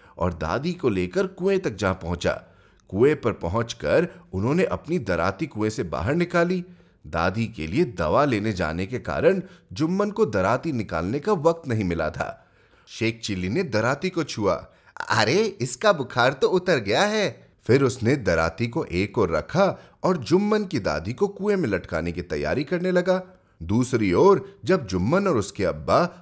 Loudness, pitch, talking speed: -24 LUFS, 140 Hz, 170 wpm